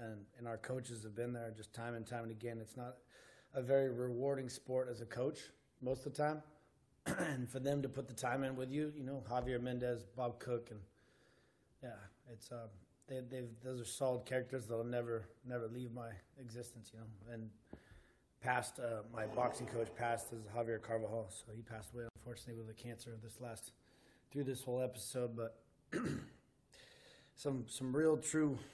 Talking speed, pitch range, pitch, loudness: 190 wpm, 115-130 Hz, 120 Hz, -43 LUFS